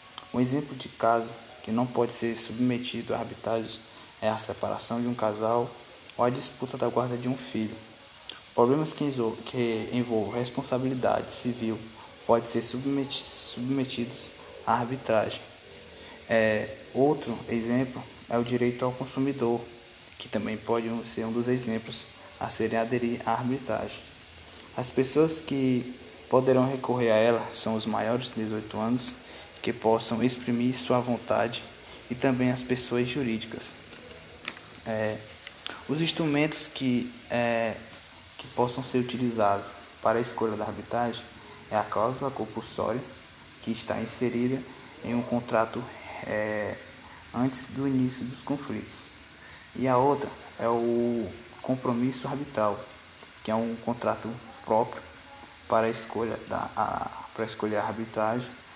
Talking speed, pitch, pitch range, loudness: 130 wpm, 120 Hz, 110-125 Hz, -29 LUFS